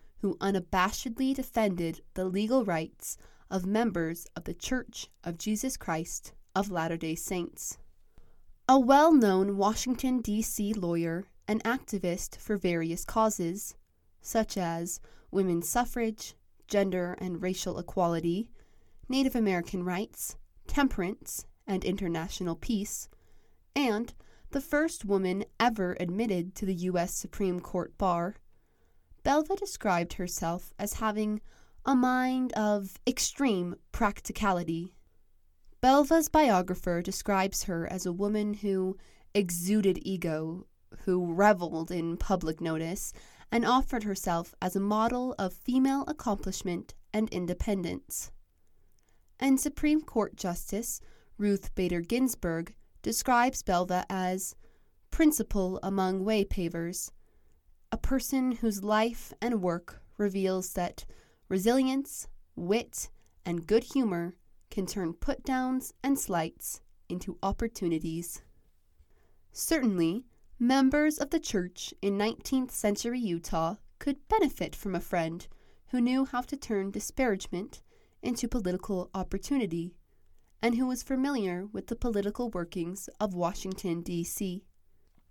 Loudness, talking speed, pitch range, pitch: -31 LUFS, 110 wpm, 175-235 Hz, 195 Hz